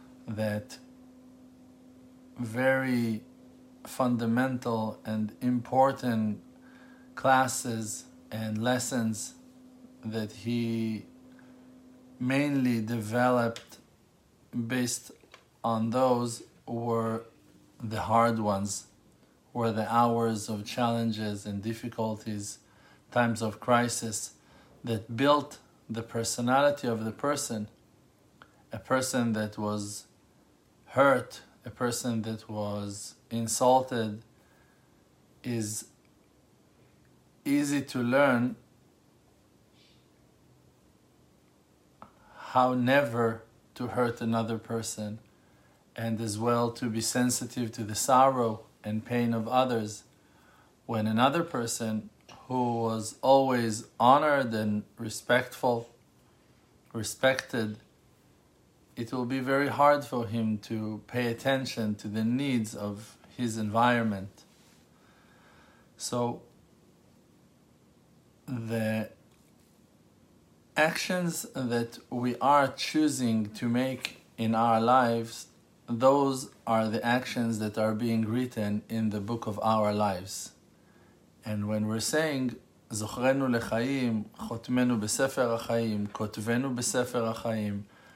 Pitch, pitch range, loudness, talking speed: 115 Hz, 110-130 Hz, -29 LUFS, 85 wpm